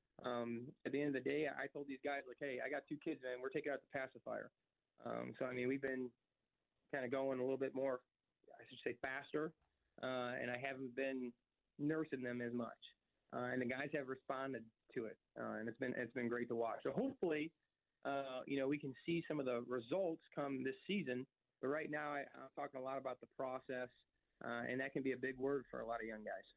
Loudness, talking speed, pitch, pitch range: -45 LUFS, 240 wpm, 130 Hz, 125-140 Hz